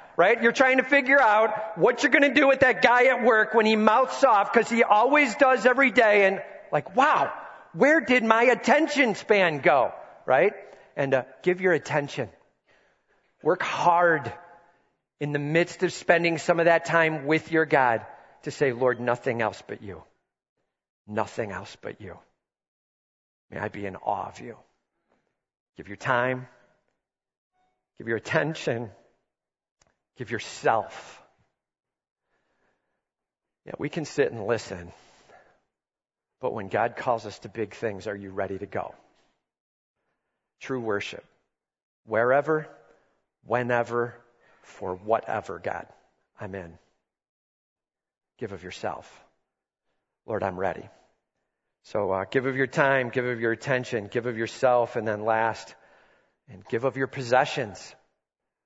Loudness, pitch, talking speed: -24 LUFS, 155 Hz, 140 wpm